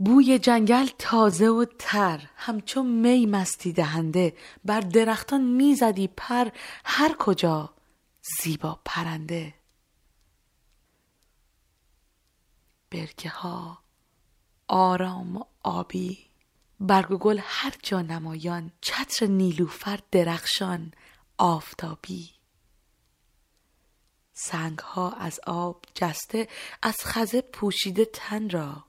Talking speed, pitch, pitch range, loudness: 85 wpm, 185 Hz, 165-225 Hz, -25 LUFS